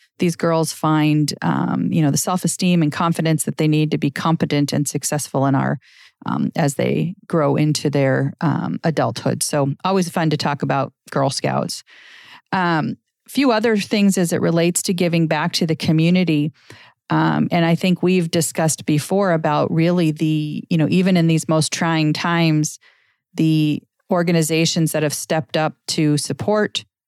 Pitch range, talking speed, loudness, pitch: 150-175 Hz, 170 wpm, -19 LUFS, 160 Hz